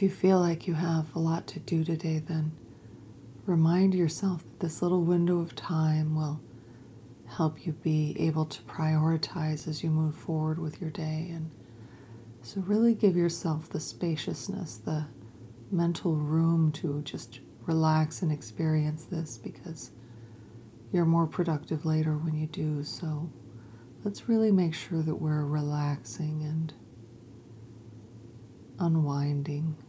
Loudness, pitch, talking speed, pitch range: -30 LUFS, 155 Hz, 135 wpm, 130-165 Hz